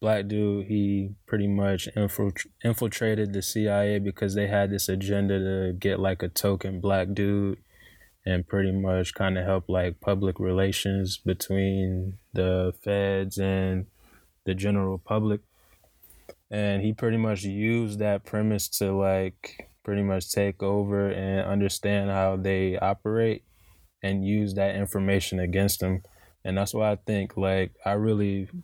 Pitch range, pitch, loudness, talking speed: 95-100 Hz, 100 Hz, -27 LUFS, 140 wpm